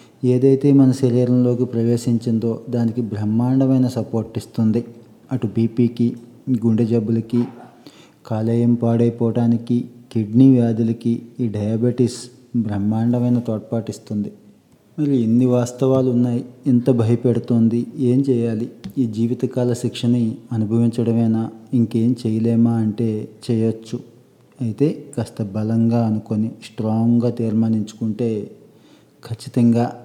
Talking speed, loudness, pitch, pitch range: 90 wpm, -19 LUFS, 120 Hz, 115-125 Hz